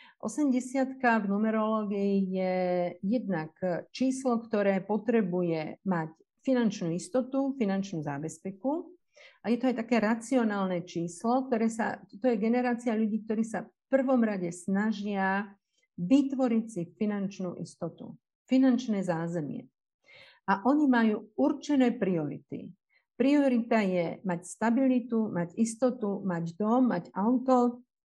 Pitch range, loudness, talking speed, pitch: 185-245 Hz, -29 LUFS, 115 wpm, 220 Hz